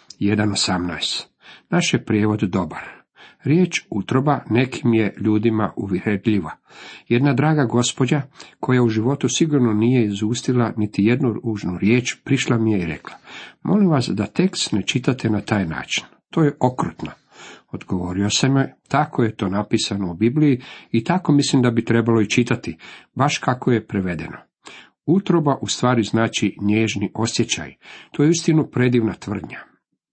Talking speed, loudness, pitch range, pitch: 145 wpm, -20 LUFS, 105-135 Hz, 120 Hz